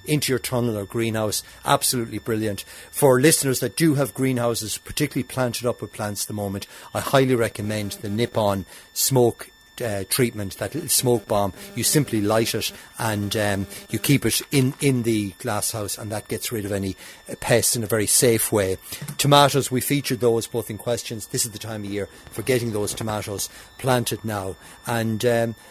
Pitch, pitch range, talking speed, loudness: 115 Hz, 105-125 Hz, 180 wpm, -22 LUFS